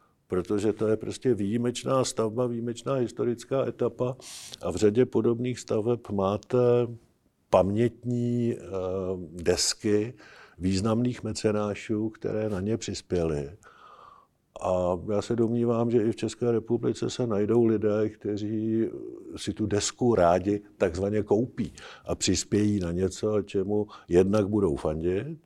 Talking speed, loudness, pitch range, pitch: 120 wpm, -27 LUFS, 100-120 Hz, 110 Hz